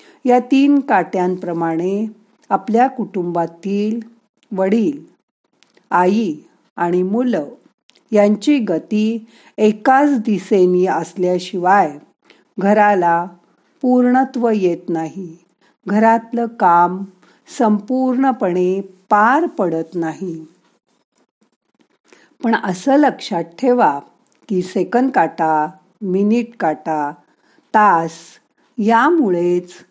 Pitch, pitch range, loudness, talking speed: 205 Hz, 180-240 Hz, -16 LUFS, 70 wpm